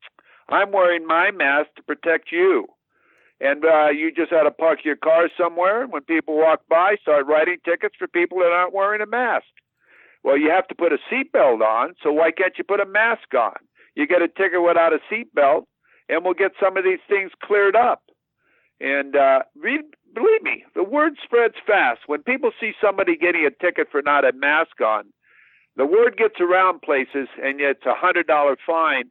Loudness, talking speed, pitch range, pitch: -19 LUFS, 200 wpm, 160-225 Hz, 180 Hz